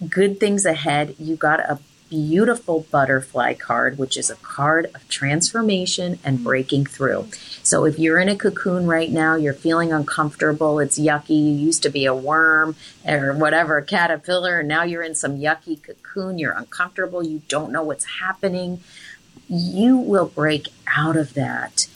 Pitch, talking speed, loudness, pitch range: 160 Hz, 165 wpm, -20 LUFS, 150-180 Hz